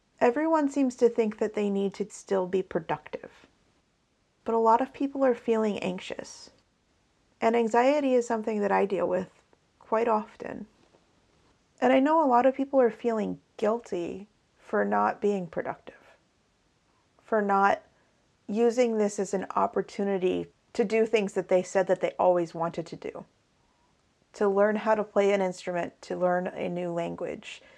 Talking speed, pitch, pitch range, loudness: 160 wpm, 210 Hz, 190-235 Hz, -27 LUFS